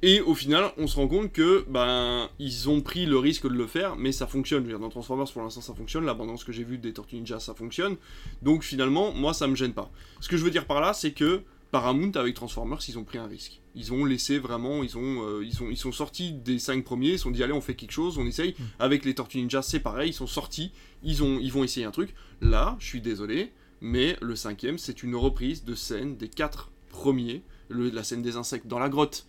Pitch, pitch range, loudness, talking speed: 130 Hz, 120-145 Hz, -28 LUFS, 255 wpm